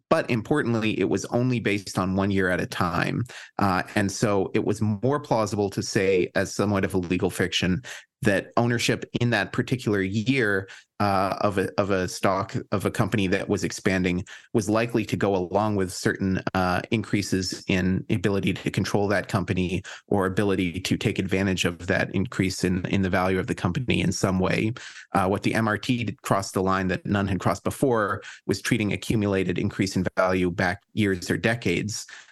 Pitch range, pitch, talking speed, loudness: 95-110 Hz, 100 Hz, 185 wpm, -25 LUFS